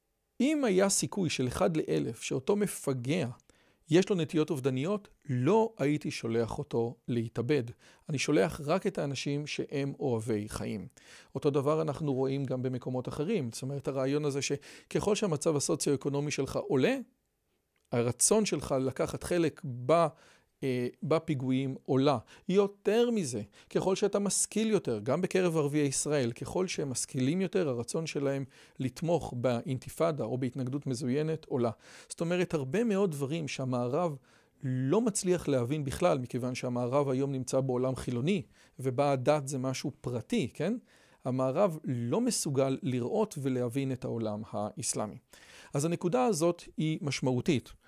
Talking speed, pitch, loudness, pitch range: 130 wpm, 145 Hz, -31 LUFS, 130-175 Hz